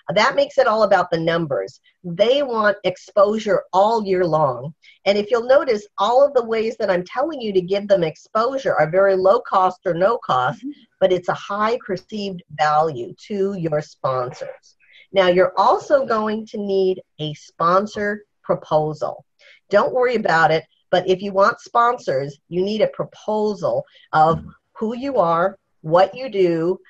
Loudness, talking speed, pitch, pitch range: -19 LUFS, 165 wpm, 195 Hz, 175-220 Hz